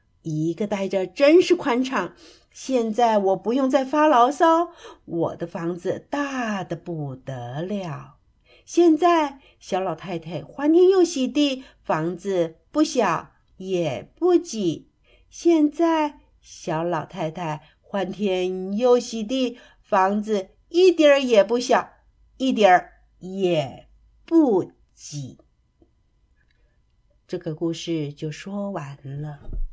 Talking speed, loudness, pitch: 155 characters per minute, -22 LUFS, 195 Hz